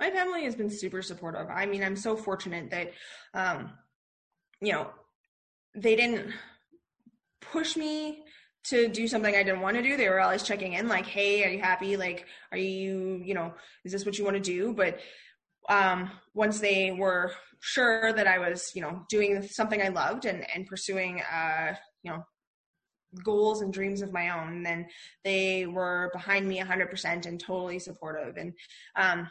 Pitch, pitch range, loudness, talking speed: 190 Hz, 180-215 Hz, -29 LUFS, 180 wpm